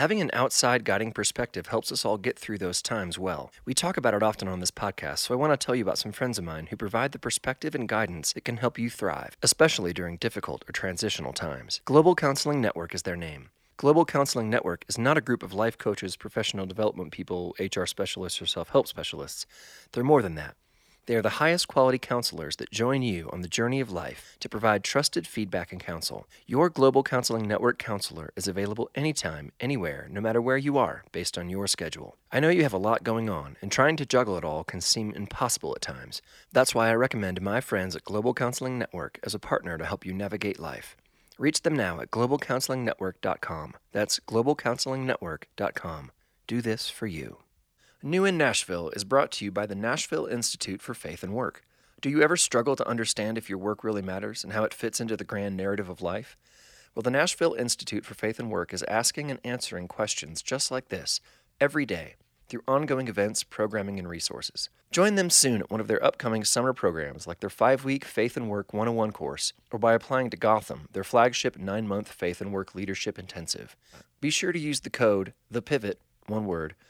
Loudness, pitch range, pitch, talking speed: -28 LUFS, 95-130 Hz, 110 Hz, 205 wpm